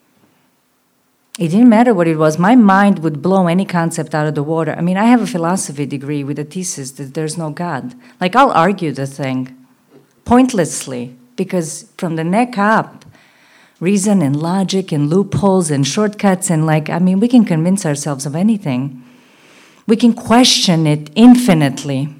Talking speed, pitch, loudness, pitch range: 170 wpm, 170 Hz, -14 LUFS, 150-200 Hz